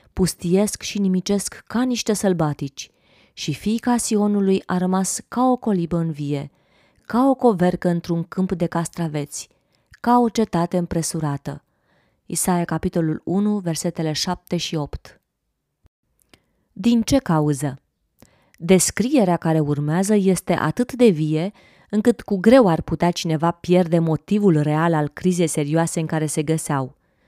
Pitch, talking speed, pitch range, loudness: 175 Hz, 130 wpm, 160-205 Hz, -20 LUFS